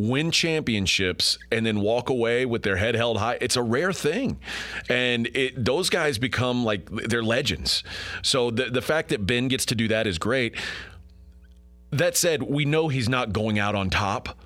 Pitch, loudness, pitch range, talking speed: 120 Hz, -24 LUFS, 105-130 Hz, 185 wpm